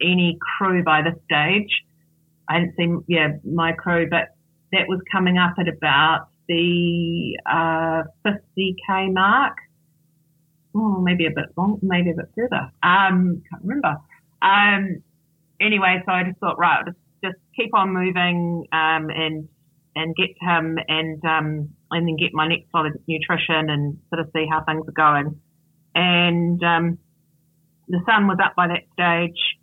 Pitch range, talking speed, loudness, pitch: 160-180 Hz, 160 wpm, -20 LUFS, 170 Hz